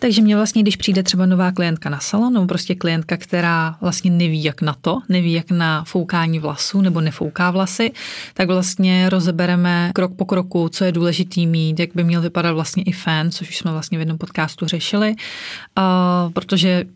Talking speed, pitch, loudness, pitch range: 185 wpm, 180 Hz, -18 LUFS, 170-185 Hz